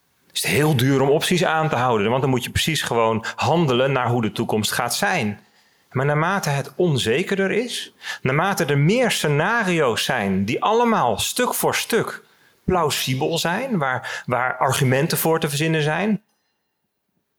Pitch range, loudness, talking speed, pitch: 125-170 Hz, -20 LUFS, 160 wpm, 150 Hz